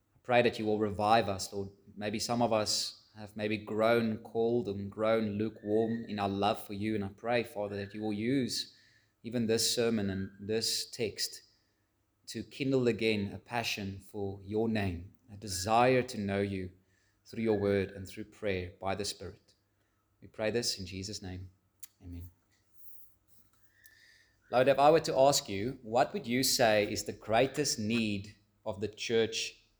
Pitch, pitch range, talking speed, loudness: 105 Hz, 100-115 Hz, 170 wpm, -32 LUFS